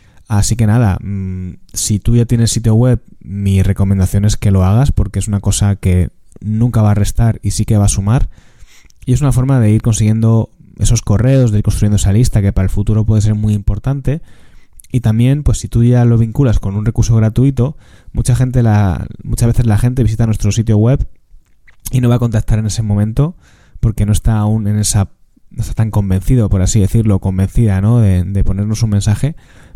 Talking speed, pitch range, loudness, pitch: 210 wpm, 100-120 Hz, -13 LUFS, 110 Hz